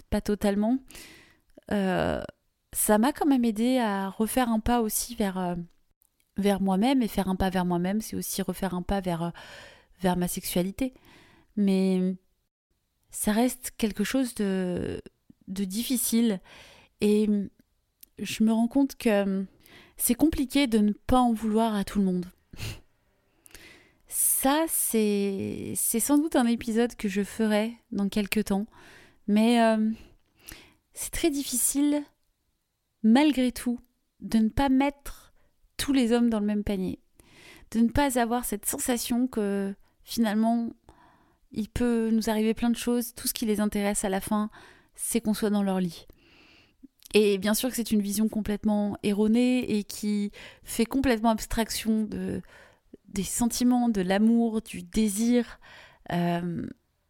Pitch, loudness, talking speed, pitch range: 220 Hz, -26 LUFS, 145 wpm, 200-240 Hz